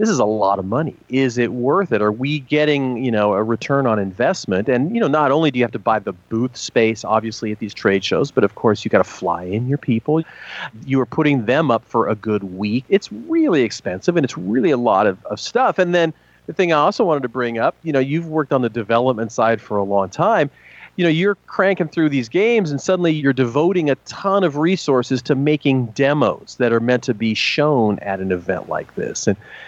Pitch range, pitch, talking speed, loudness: 115-155 Hz, 130 Hz, 240 wpm, -18 LUFS